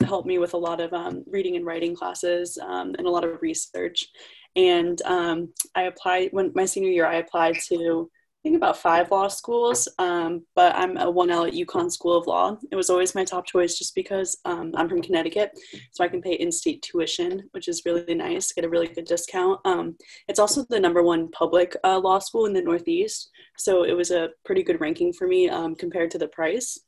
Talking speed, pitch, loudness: 220 wpm, 185 Hz, -24 LUFS